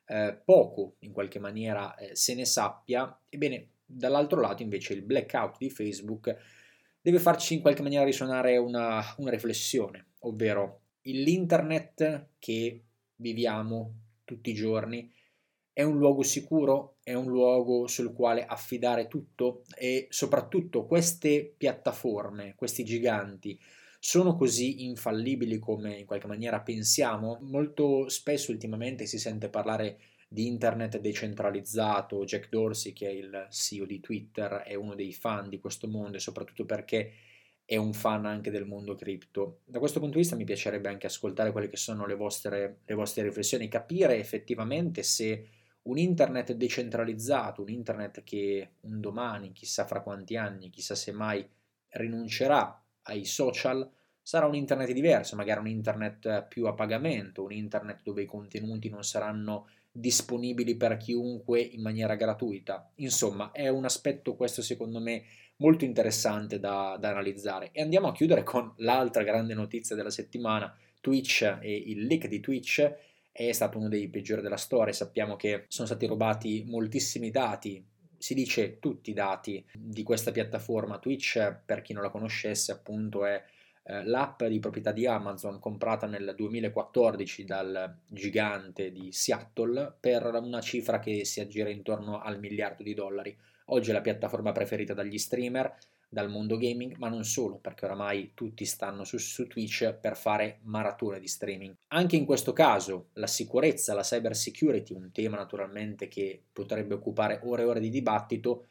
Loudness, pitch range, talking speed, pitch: -31 LUFS, 105-125 Hz, 155 wpm, 110 Hz